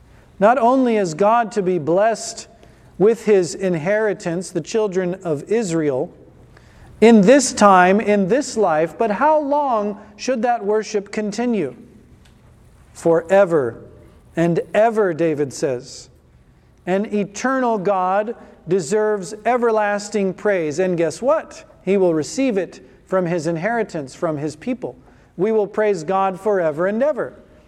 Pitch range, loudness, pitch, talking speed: 175-225 Hz, -18 LUFS, 205 Hz, 125 wpm